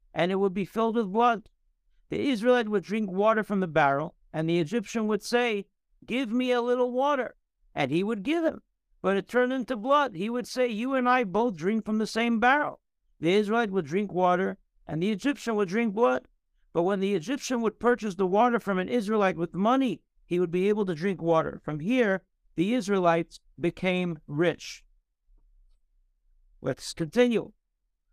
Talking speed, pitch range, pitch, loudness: 185 wpm, 180-245 Hz, 210 Hz, -27 LUFS